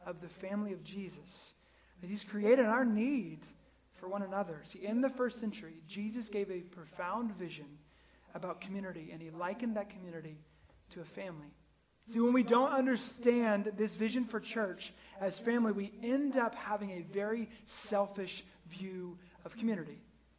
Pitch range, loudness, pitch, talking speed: 175-225 Hz, -36 LUFS, 200 Hz, 160 wpm